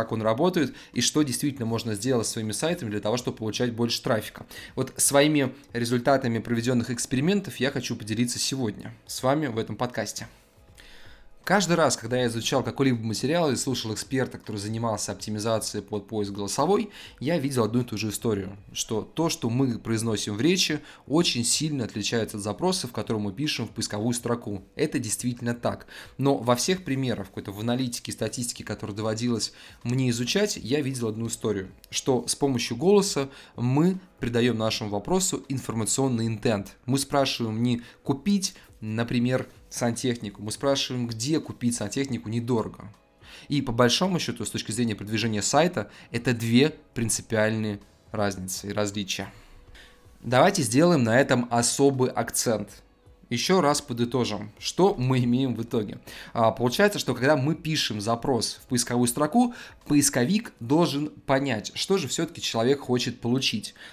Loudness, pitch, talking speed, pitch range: -26 LUFS, 120 Hz, 150 wpm, 110-135 Hz